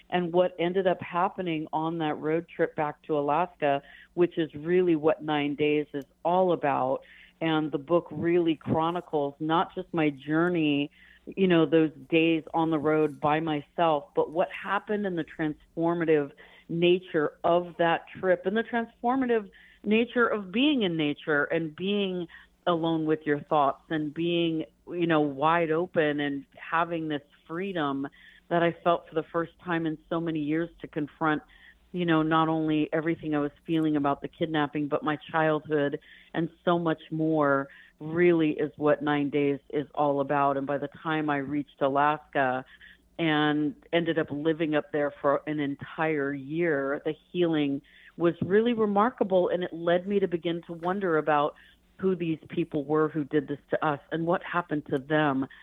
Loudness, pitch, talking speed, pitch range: -28 LUFS, 160 Hz, 170 wpm, 150-170 Hz